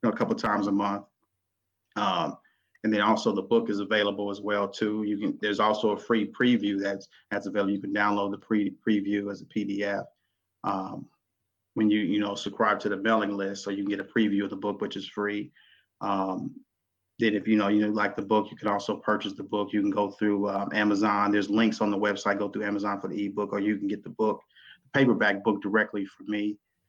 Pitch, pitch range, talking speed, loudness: 100 Hz, 100-105 Hz, 230 wpm, -28 LUFS